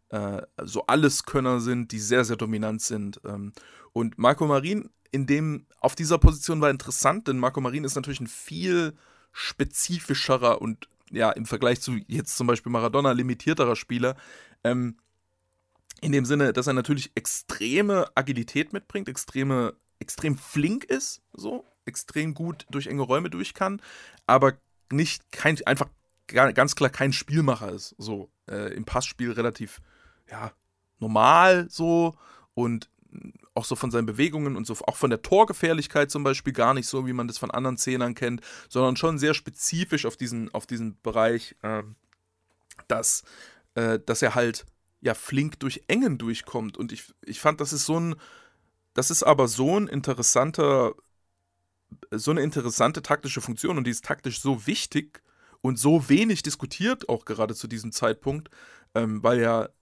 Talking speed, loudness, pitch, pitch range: 155 wpm, -25 LUFS, 130 Hz, 115-150 Hz